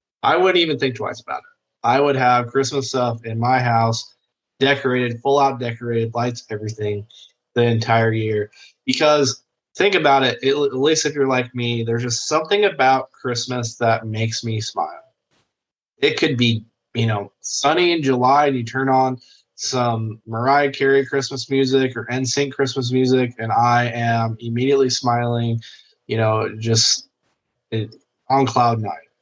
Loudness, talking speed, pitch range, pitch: -19 LUFS, 160 wpm, 115-135 Hz, 125 Hz